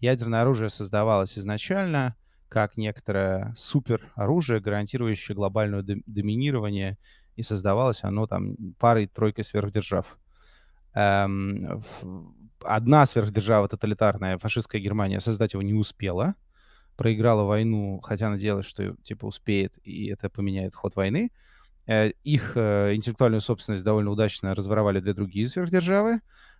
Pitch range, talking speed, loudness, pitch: 100-115 Hz, 105 wpm, -26 LUFS, 105 Hz